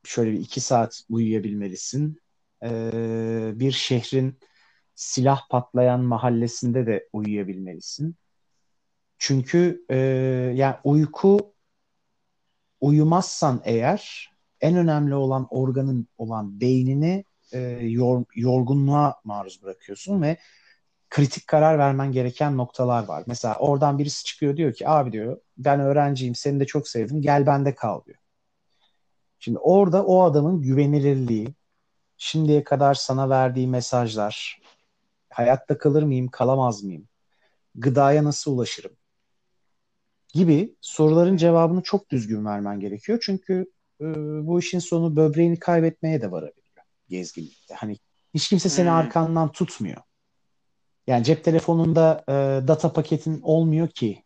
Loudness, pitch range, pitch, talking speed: -22 LUFS, 125-160 Hz, 140 Hz, 115 wpm